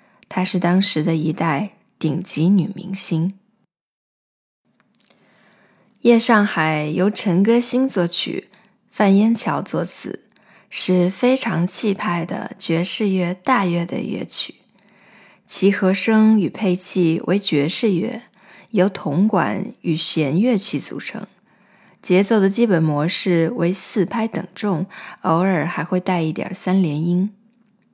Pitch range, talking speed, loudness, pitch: 175-215 Hz, 175 characters per minute, -17 LUFS, 190 Hz